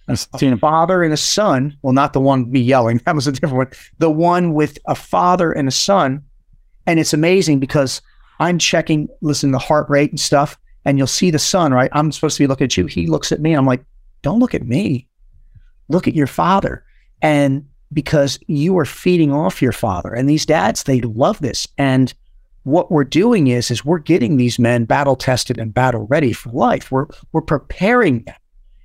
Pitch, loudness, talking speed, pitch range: 140 Hz, -16 LUFS, 205 wpm, 130-155 Hz